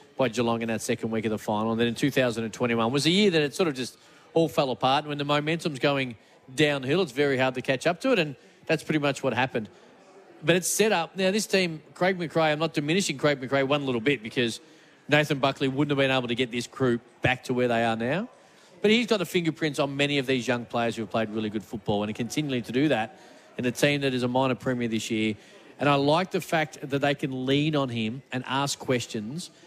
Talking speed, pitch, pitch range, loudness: 255 wpm, 140 Hz, 120-155 Hz, -26 LUFS